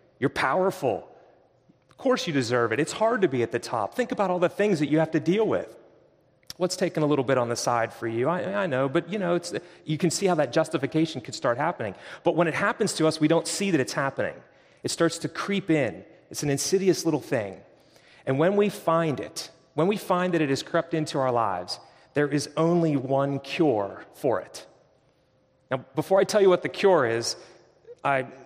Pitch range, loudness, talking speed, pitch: 135-185 Hz, -25 LUFS, 220 wpm, 160 Hz